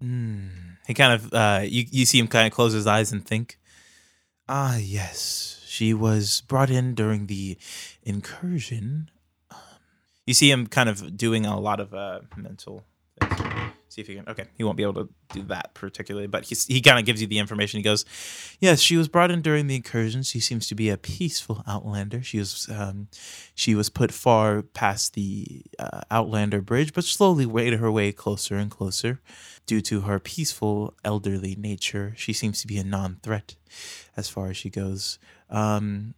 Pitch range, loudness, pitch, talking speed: 100-120 Hz, -23 LUFS, 110 Hz, 190 wpm